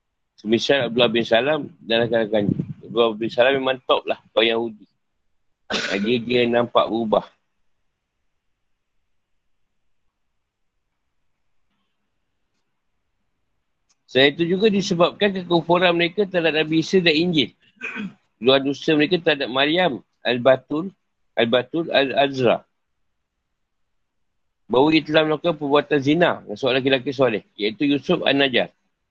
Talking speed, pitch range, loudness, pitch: 105 wpm, 115-165 Hz, -20 LUFS, 140 Hz